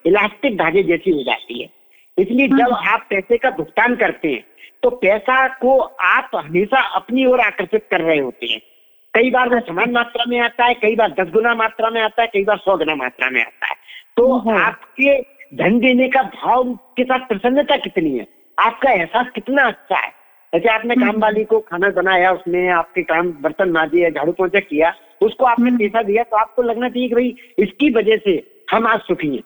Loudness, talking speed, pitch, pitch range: -16 LUFS, 200 wpm, 225 Hz, 190-250 Hz